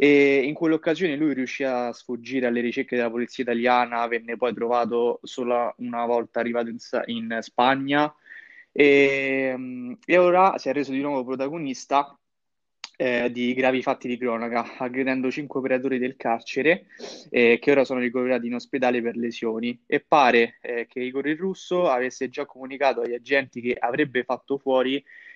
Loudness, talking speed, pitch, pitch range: -23 LUFS, 155 wpm, 130 Hz, 120-140 Hz